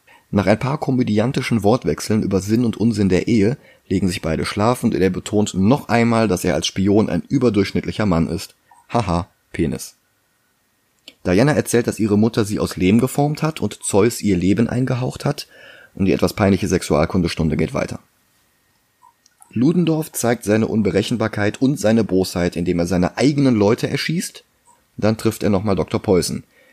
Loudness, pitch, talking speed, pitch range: -19 LUFS, 105 Hz, 160 wpm, 95-120 Hz